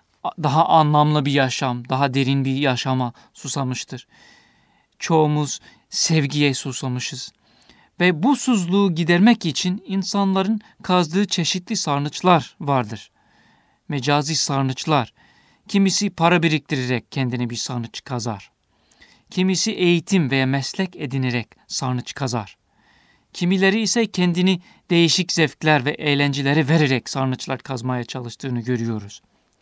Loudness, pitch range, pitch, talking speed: -20 LUFS, 130-180 Hz, 150 Hz, 100 wpm